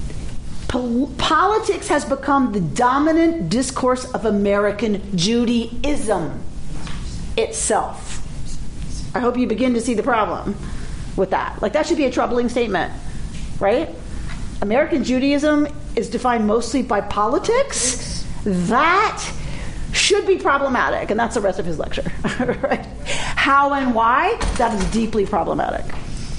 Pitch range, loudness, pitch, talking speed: 215-280 Hz, -19 LUFS, 245 Hz, 125 wpm